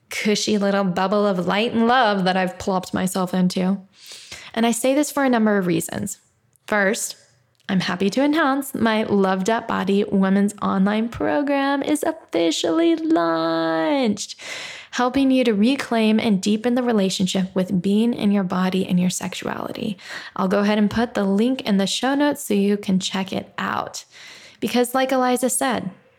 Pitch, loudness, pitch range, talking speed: 210 Hz, -20 LUFS, 190-255 Hz, 165 wpm